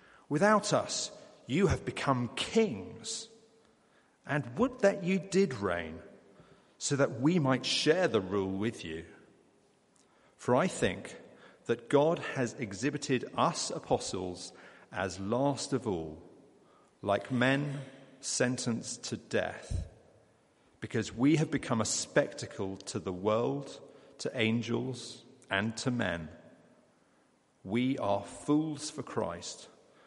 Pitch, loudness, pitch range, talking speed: 125 Hz, -32 LUFS, 100-145 Hz, 115 wpm